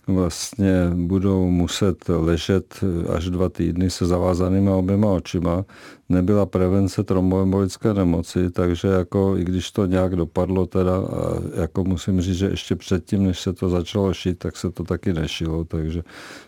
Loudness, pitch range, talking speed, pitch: -21 LUFS, 90-95 Hz, 150 wpm, 90 Hz